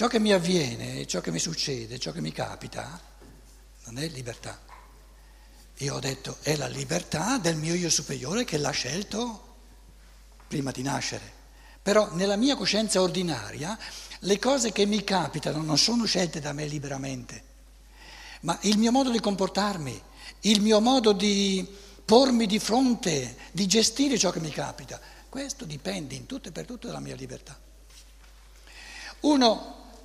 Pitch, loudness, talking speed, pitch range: 195 Hz, -26 LUFS, 155 wpm, 150-230 Hz